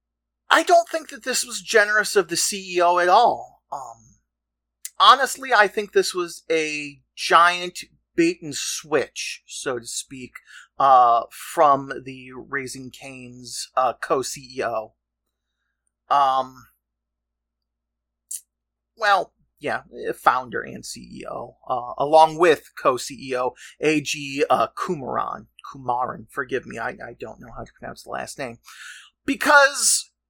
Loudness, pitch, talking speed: -21 LUFS, 130 Hz, 125 wpm